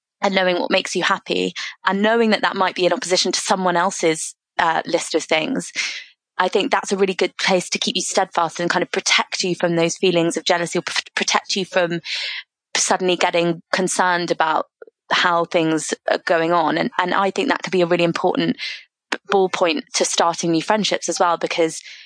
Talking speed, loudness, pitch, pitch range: 200 wpm, -19 LUFS, 180 Hz, 170-190 Hz